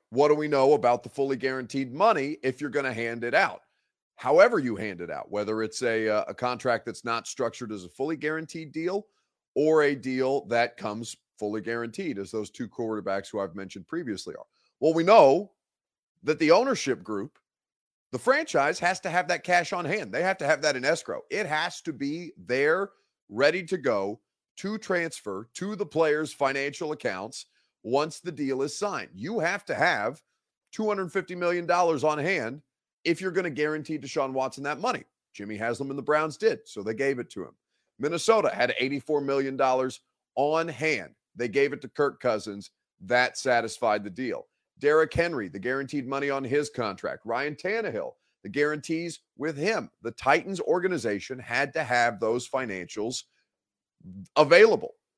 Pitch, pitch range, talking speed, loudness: 140 Hz, 120-165 Hz, 175 wpm, -27 LUFS